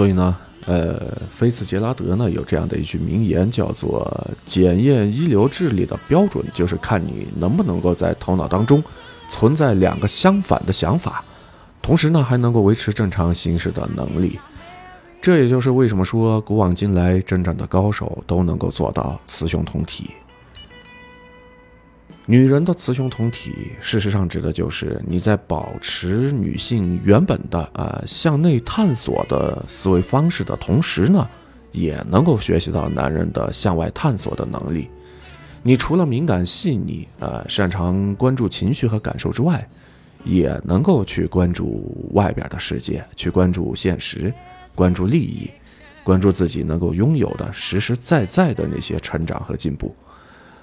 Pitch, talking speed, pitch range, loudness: 100 Hz, 245 characters per minute, 90-120 Hz, -19 LUFS